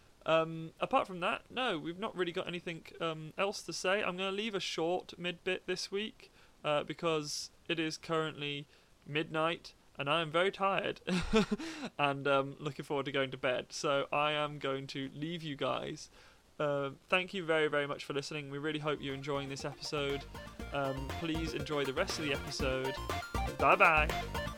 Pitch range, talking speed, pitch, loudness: 140-175 Hz, 185 wpm, 155 Hz, -35 LUFS